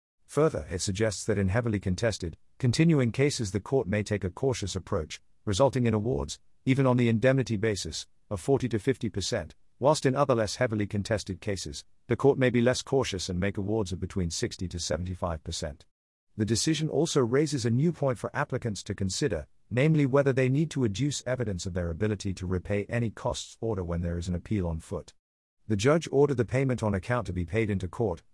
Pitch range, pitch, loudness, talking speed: 95-130 Hz, 110 Hz, -28 LUFS, 205 wpm